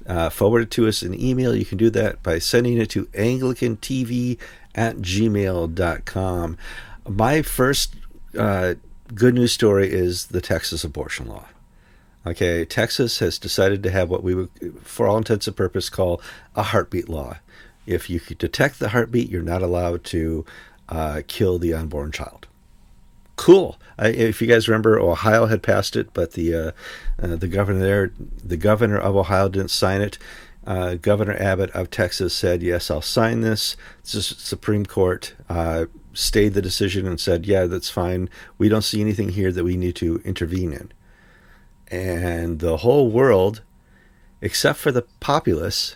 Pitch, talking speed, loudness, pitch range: 95 Hz, 165 wpm, -21 LUFS, 85-110 Hz